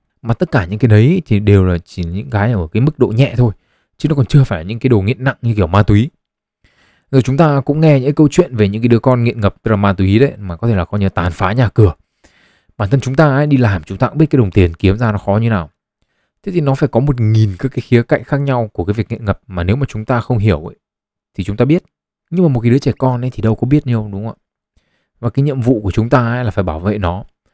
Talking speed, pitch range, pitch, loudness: 305 wpm, 100-135 Hz, 115 Hz, -14 LUFS